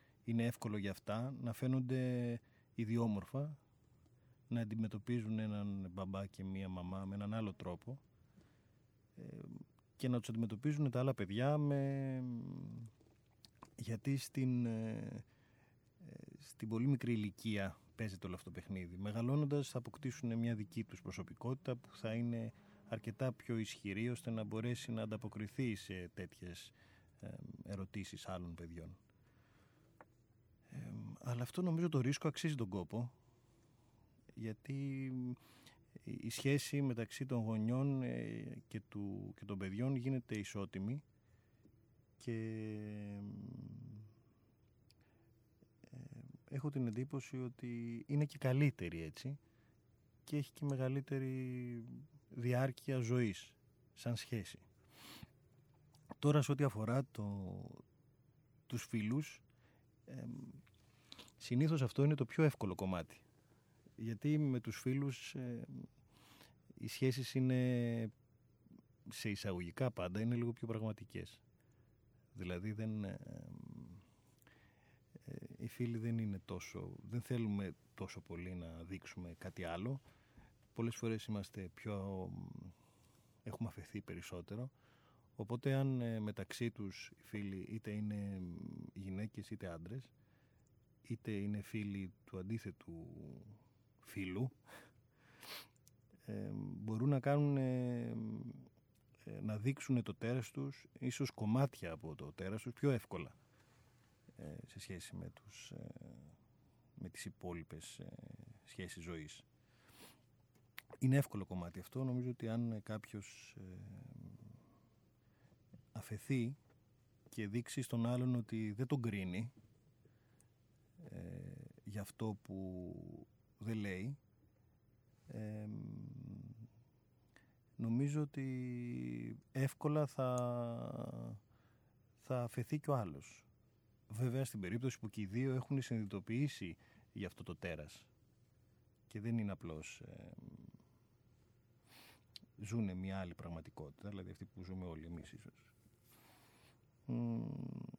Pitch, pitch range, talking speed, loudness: 115 Hz, 105-130 Hz, 105 wpm, -43 LUFS